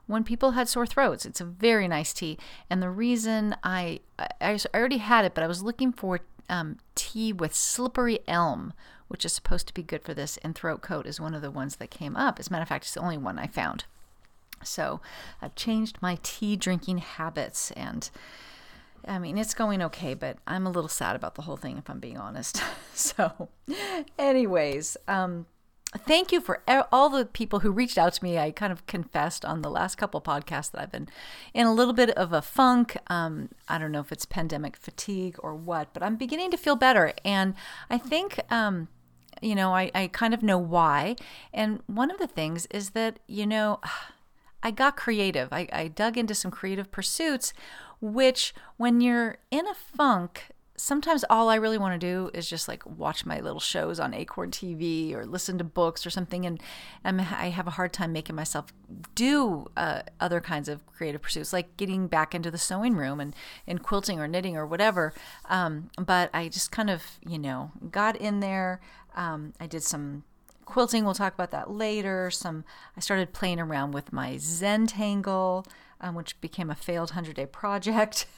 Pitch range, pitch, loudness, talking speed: 170-225 Hz, 190 Hz, -28 LUFS, 200 wpm